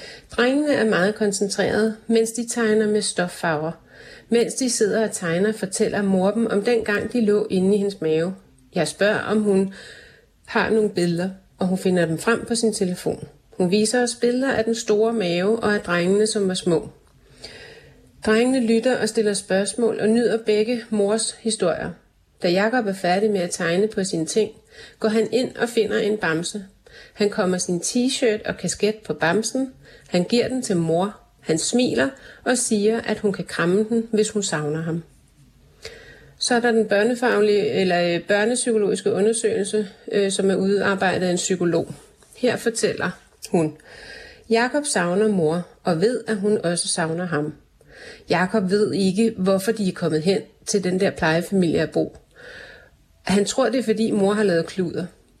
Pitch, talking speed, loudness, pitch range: 210 Hz, 170 wpm, -21 LUFS, 180-225 Hz